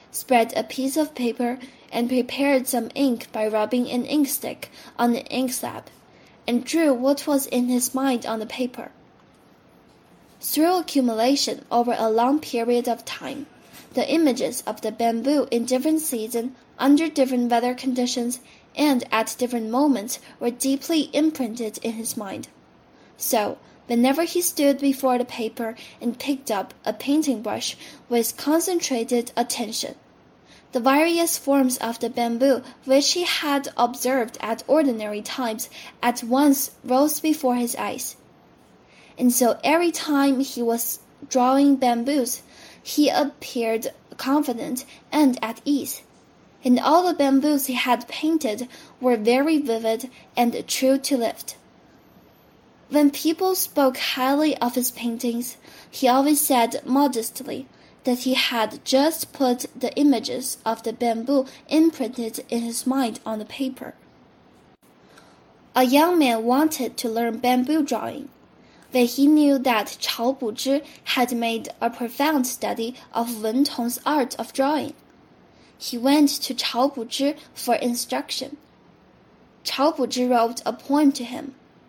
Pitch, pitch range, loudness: 255 Hz, 235-280 Hz, -22 LUFS